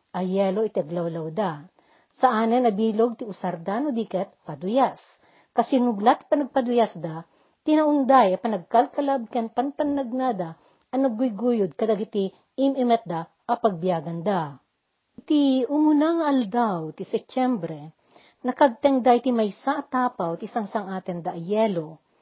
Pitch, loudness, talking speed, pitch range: 230 Hz, -24 LUFS, 110 wpm, 185-260 Hz